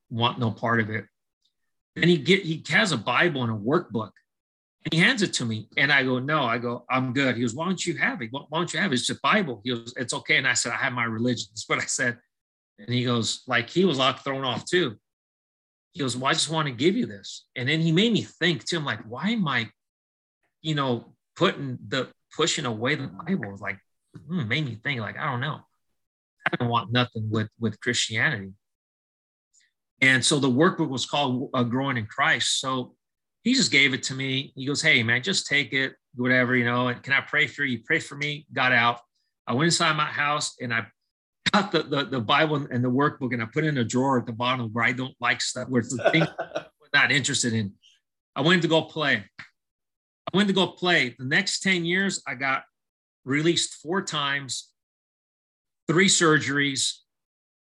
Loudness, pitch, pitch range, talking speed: -24 LUFS, 130 Hz, 120-155 Hz, 225 wpm